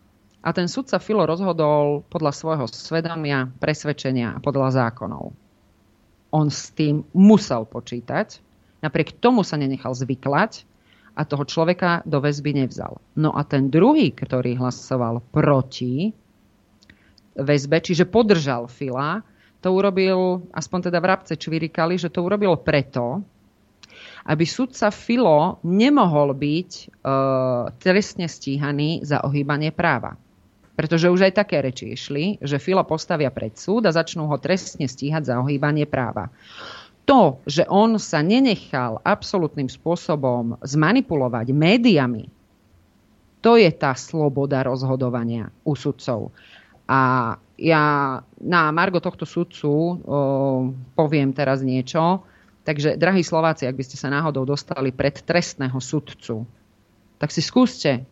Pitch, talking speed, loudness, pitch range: 145 Hz, 125 wpm, -21 LUFS, 130-170 Hz